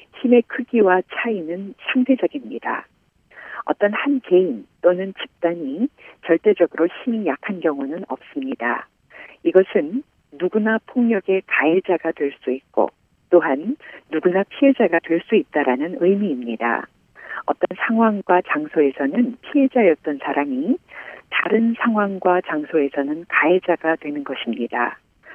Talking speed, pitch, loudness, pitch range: 270 characters per minute, 190 Hz, -20 LUFS, 160-240 Hz